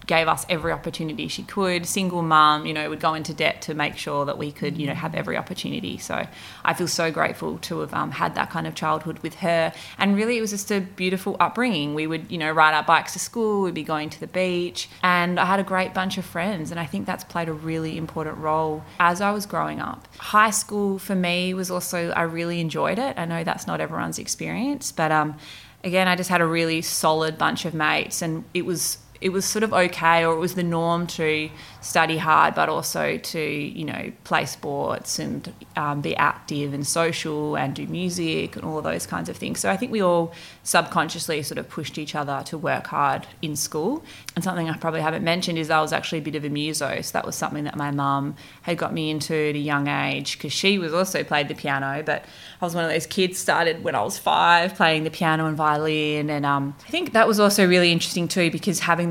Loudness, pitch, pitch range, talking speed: -23 LUFS, 165 Hz, 155-180 Hz, 240 wpm